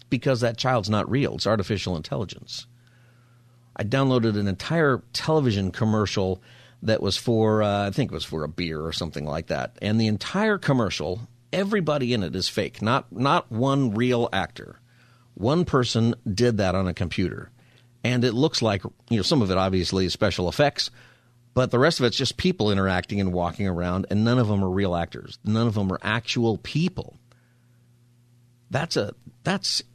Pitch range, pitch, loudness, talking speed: 100-125 Hz, 115 Hz, -24 LUFS, 180 wpm